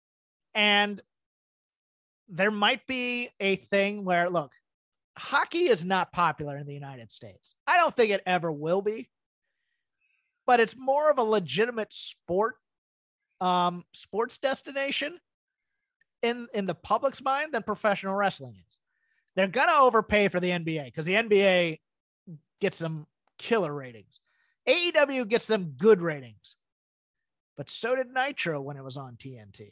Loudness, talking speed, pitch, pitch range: -26 LUFS, 140 wpm, 205 Hz, 170-255 Hz